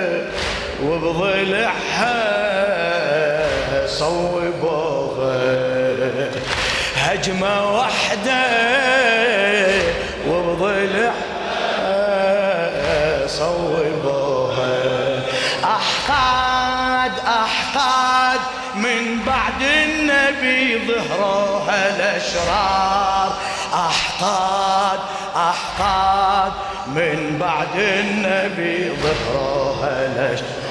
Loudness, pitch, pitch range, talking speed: -18 LUFS, 195 Hz, 190-240 Hz, 40 wpm